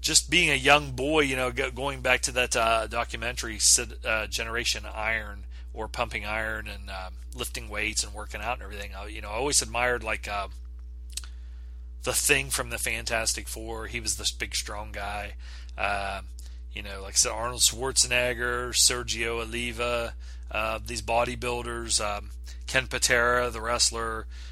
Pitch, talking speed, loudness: 115 Hz, 165 wpm, -26 LUFS